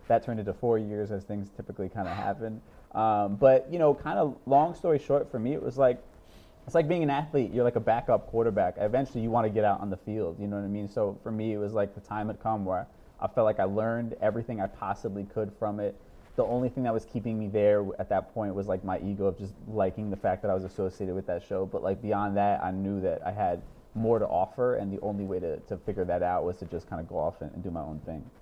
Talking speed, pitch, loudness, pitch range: 280 wpm, 105 Hz, -29 LUFS, 100-115 Hz